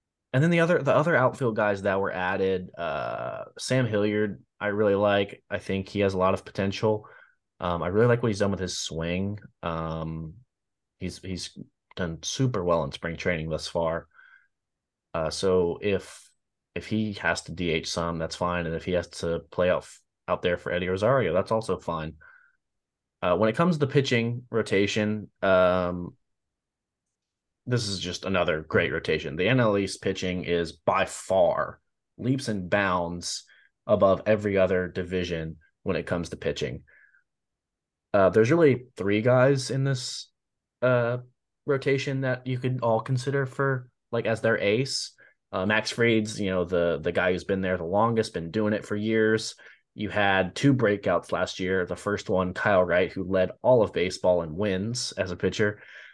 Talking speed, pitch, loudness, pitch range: 175 wpm, 100 Hz, -26 LUFS, 90-115 Hz